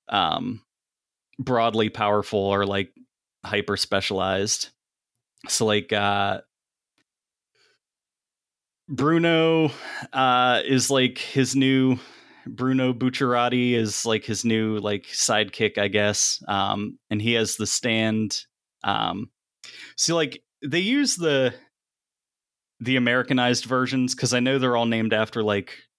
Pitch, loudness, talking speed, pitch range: 120 Hz, -23 LUFS, 115 wpm, 105-130 Hz